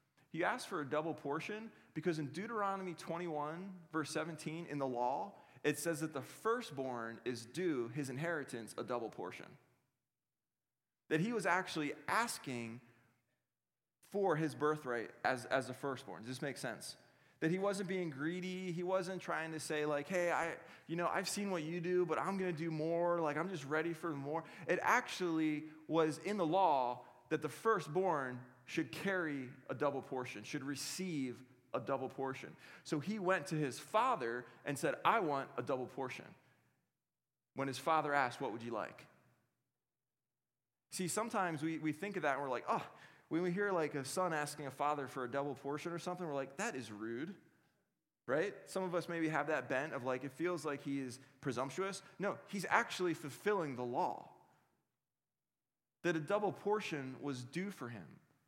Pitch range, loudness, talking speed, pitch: 135-180 Hz, -39 LUFS, 180 wpm, 155 Hz